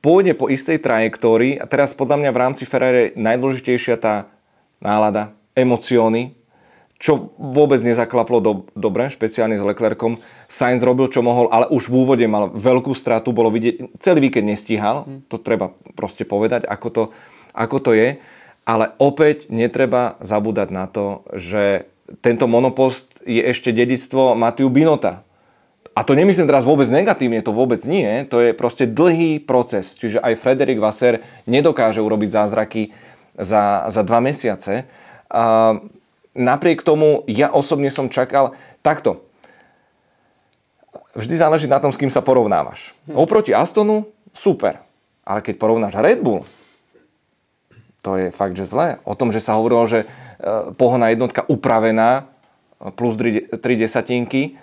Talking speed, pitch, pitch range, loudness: 140 wpm, 120 Hz, 110-135 Hz, -17 LUFS